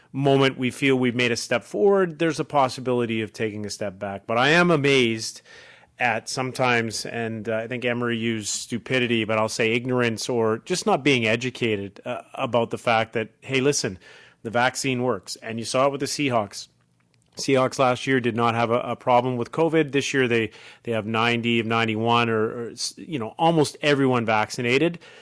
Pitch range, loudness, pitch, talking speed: 115-135 Hz, -23 LUFS, 120 Hz, 190 wpm